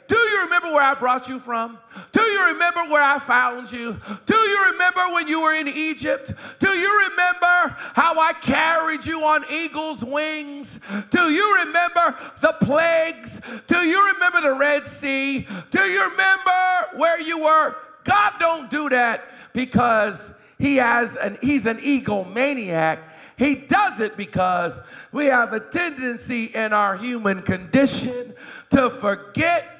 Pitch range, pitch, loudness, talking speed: 245-340 Hz, 290 Hz, -20 LUFS, 155 wpm